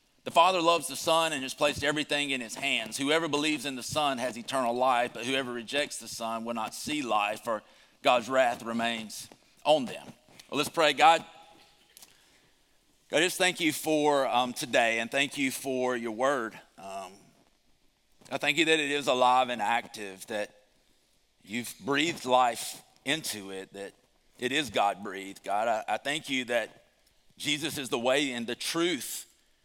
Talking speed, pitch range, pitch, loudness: 170 wpm, 115-145 Hz, 130 Hz, -28 LUFS